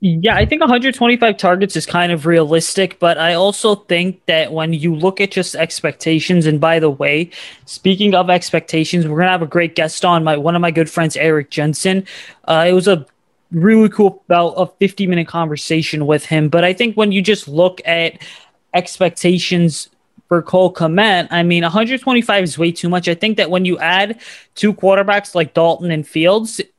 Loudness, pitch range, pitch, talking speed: -14 LUFS, 165-195 Hz, 175 Hz, 195 wpm